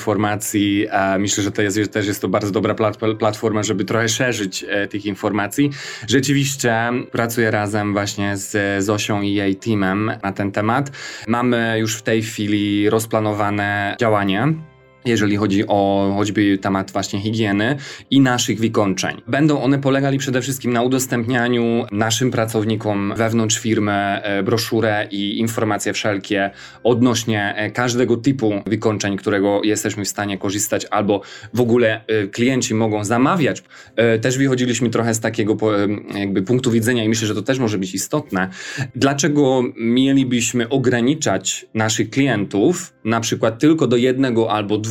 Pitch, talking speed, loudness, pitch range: 110 Hz, 150 wpm, -18 LUFS, 105-120 Hz